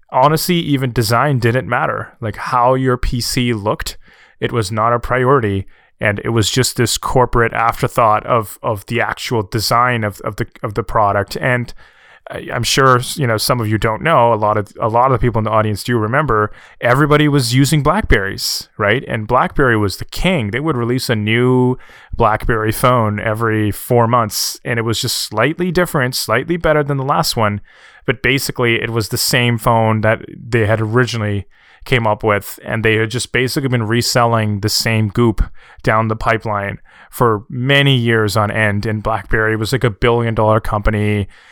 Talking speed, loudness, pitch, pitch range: 185 wpm, -15 LUFS, 115 Hz, 110-125 Hz